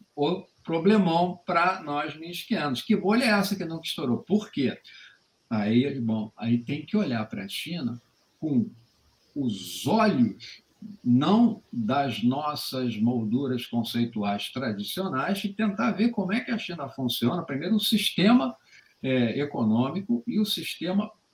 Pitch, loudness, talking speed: 170 Hz, -26 LUFS, 140 wpm